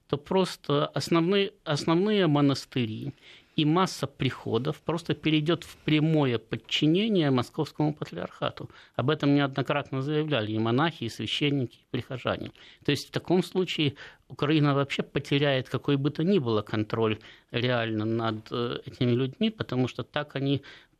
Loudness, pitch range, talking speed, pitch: -27 LUFS, 125-155 Hz, 135 wpm, 140 Hz